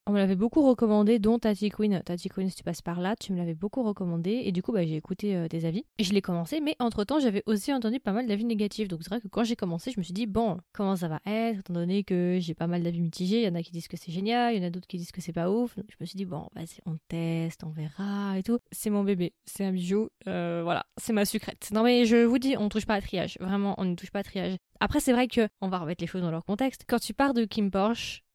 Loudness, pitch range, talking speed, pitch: -29 LUFS, 175-225 Hz, 305 wpm, 200 Hz